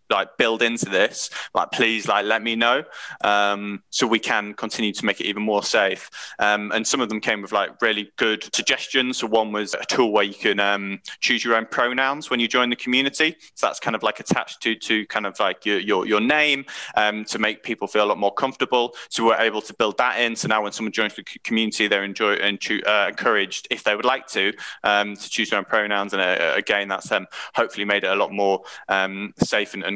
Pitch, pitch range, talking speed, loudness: 110 Hz, 100-115 Hz, 240 wpm, -21 LUFS